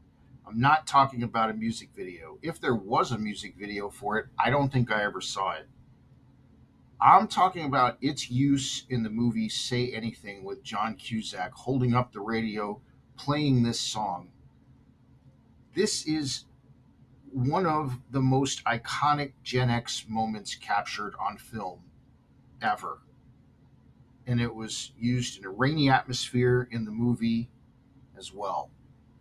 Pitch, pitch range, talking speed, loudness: 125 Hz, 110-130 Hz, 140 wpm, -28 LUFS